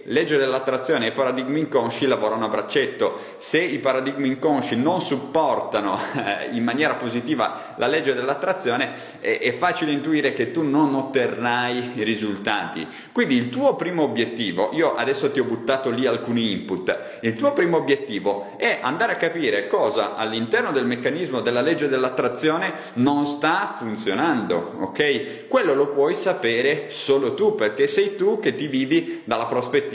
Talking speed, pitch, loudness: 155 wpm, 155 Hz, -22 LUFS